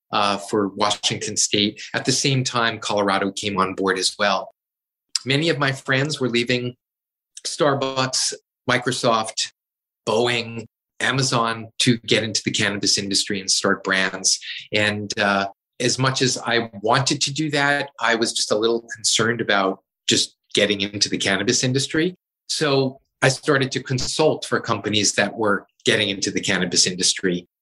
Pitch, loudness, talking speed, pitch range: 115 Hz, -20 LUFS, 150 wpm, 105-130 Hz